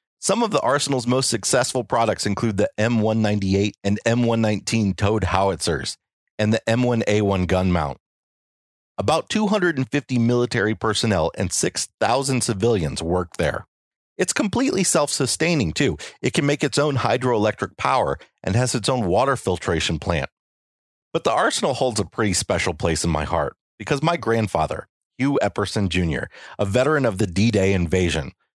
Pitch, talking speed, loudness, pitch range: 110 Hz, 145 wpm, -21 LUFS, 95-125 Hz